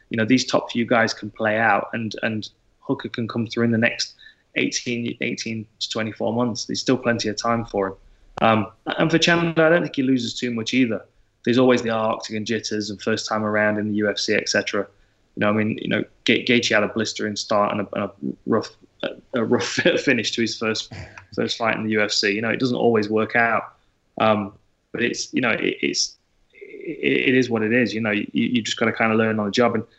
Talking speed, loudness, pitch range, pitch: 240 wpm, -21 LUFS, 105-120 Hz, 110 Hz